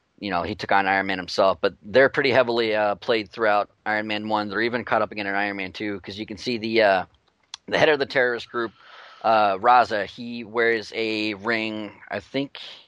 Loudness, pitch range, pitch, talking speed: -23 LUFS, 100-115 Hz, 110 Hz, 220 wpm